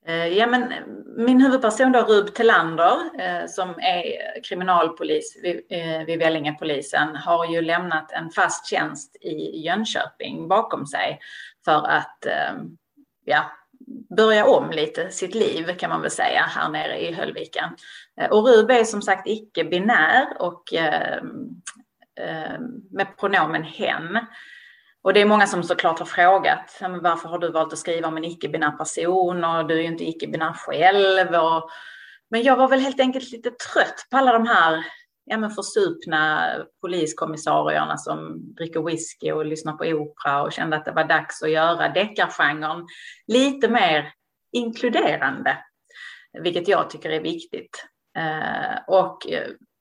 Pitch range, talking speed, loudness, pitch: 165-245 Hz, 145 wpm, -21 LUFS, 185 Hz